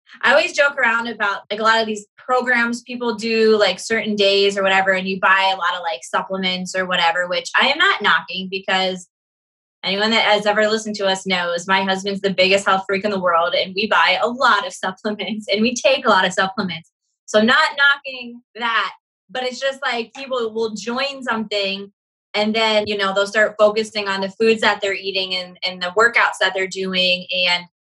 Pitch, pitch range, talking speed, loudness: 205 Hz, 190-225 Hz, 210 wpm, -18 LUFS